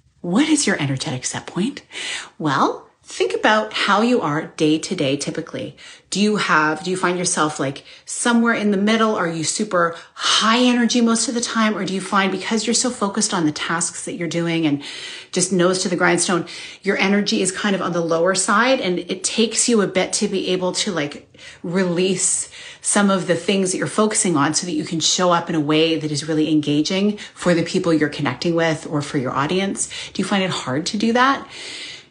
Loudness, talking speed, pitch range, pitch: -19 LUFS, 220 wpm, 165-215 Hz, 185 Hz